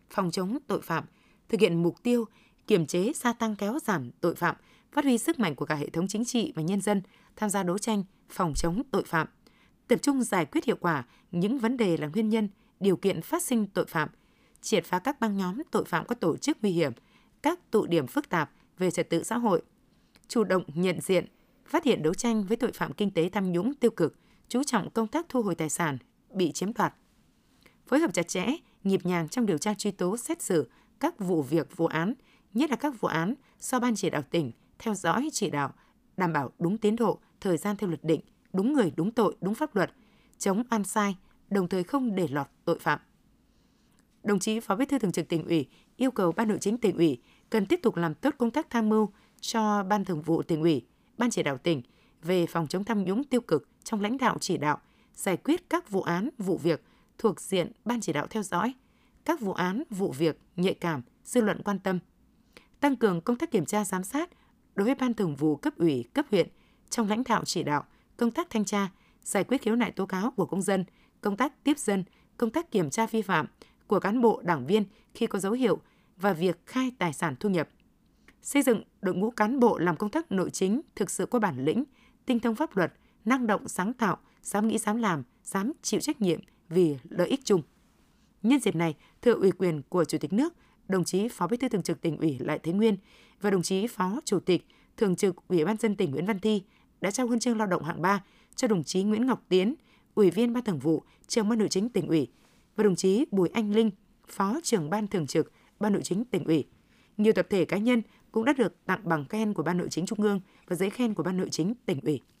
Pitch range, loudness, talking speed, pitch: 175-230 Hz, -28 LUFS, 235 wpm, 205 Hz